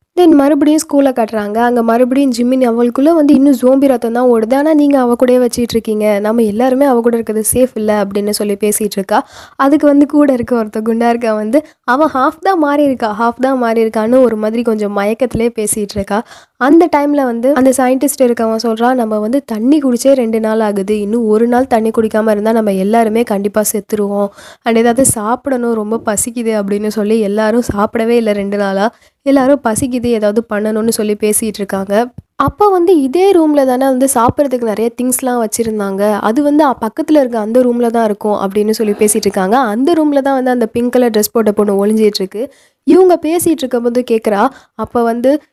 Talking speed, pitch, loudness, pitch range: 175 wpm, 235 Hz, -12 LUFS, 215-265 Hz